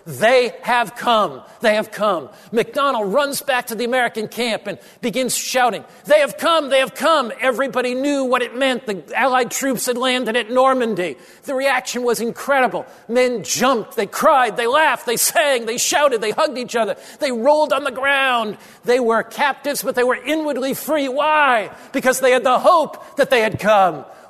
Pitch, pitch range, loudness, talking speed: 250 Hz, 230-275 Hz, -18 LUFS, 185 wpm